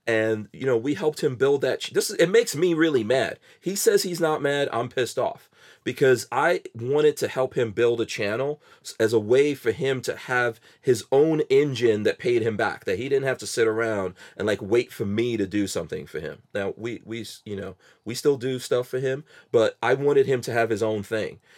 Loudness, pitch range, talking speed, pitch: -24 LUFS, 115-175 Hz, 235 wpm, 130 Hz